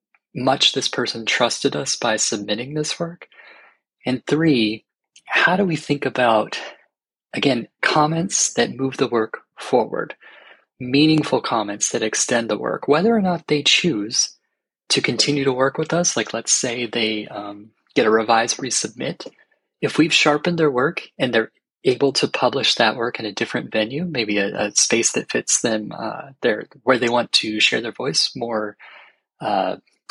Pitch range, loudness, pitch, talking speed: 110-150 Hz, -19 LUFS, 125 Hz, 165 wpm